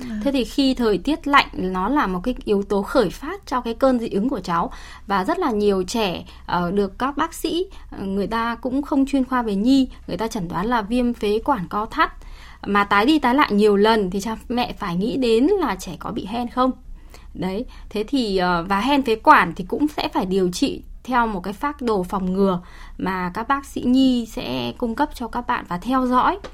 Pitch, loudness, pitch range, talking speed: 230 Hz, -21 LUFS, 200-265 Hz, 230 wpm